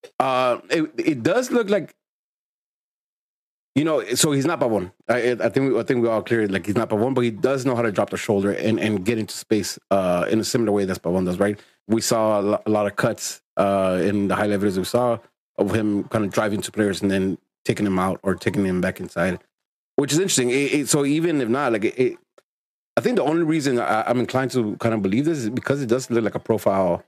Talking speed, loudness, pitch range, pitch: 255 wpm, -22 LUFS, 100-130 Hz, 110 Hz